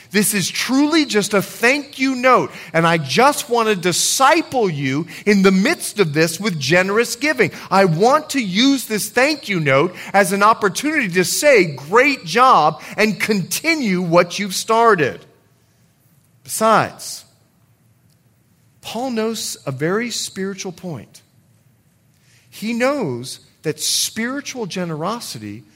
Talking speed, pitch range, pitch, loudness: 130 wpm, 165-235 Hz, 200 Hz, -17 LUFS